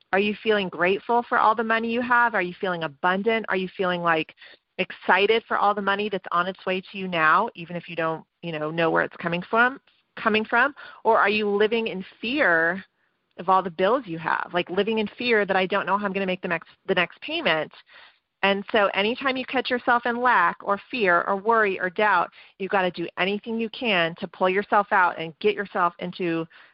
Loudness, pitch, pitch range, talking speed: -23 LUFS, 195 Hz, 180-225 Hz, 230 wpm